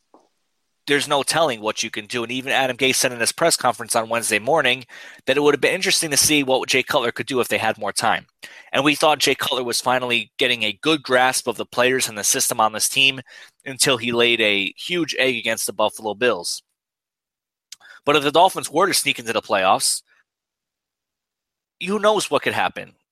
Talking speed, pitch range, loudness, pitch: 215 wpm, 115-145 Hz, -19 LUFS, 130 Hz